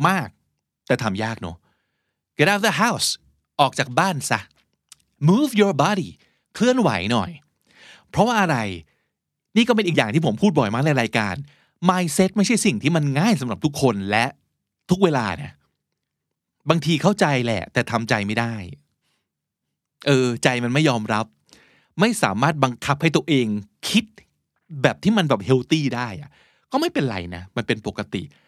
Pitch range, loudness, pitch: 110-175 Hz, -21 LUFS, 140 Hz